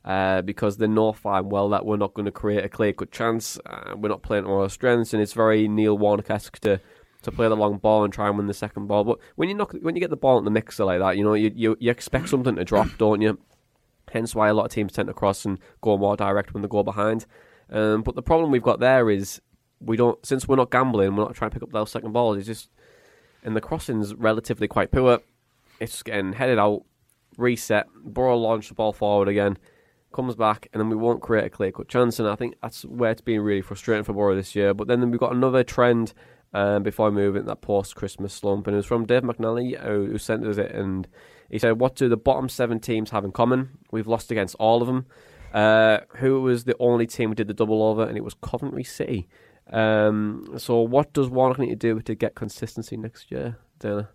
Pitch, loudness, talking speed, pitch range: 110 Hz, -23 LUFS, 245 wpm, 105-120 Hz